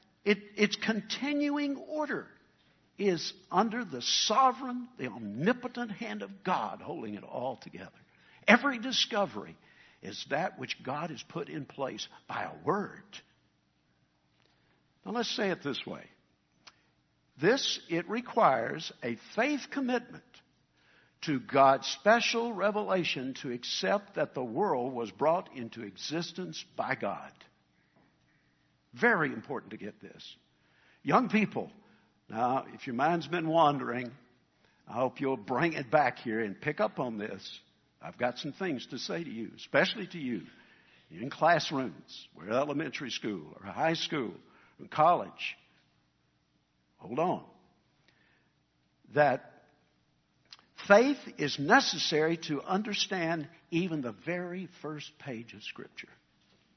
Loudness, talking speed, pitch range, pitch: -31 LUFS, 125 wpm, 135-215 Hz, 170 Hz